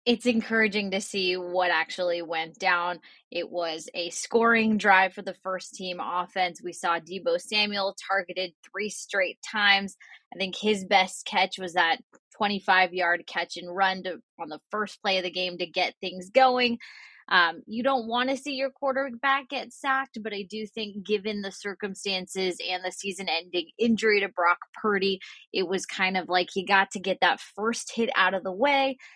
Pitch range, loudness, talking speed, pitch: 185-225 Hz, -26 LUFS, 185 wpm, 195 Hz